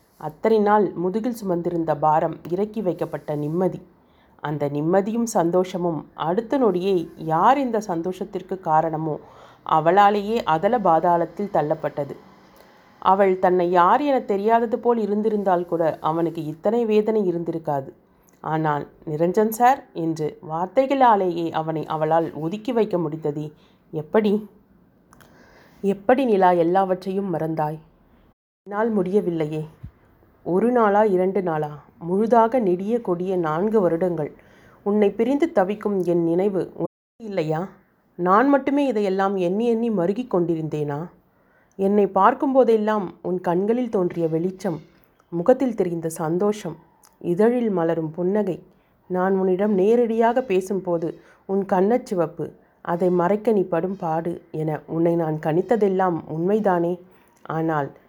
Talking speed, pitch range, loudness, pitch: 105 wpm, 165-210 Hz, -22 LUFS, 180 Hz